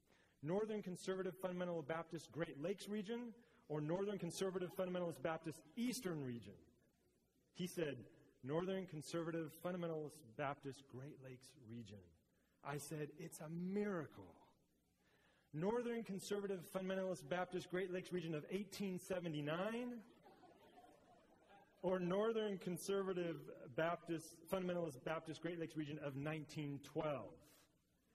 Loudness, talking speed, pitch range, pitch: -46 LUFS, 100 wpm, 150-190 Hz, 170 Hz